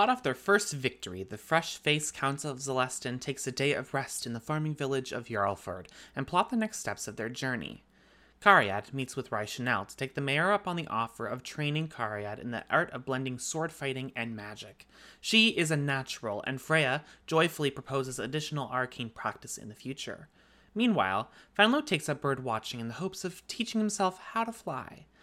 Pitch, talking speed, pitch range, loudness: 135 Hz, 195 wpm, 120-160 Hz, -31 LUFS